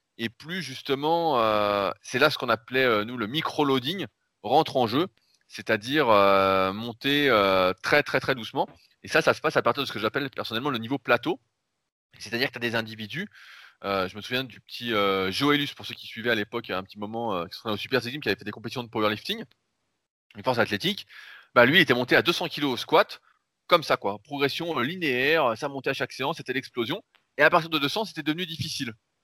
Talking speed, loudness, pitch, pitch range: 225 wpm, -25 LUFS, 125 Hz, 105-145 Hz